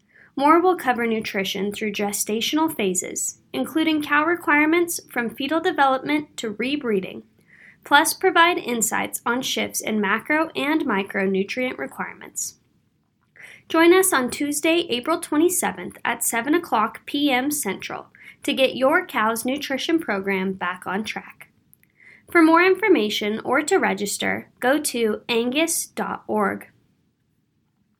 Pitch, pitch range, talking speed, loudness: 265 Hz, 220-320 Hz, 115 wpm, -21 LUFS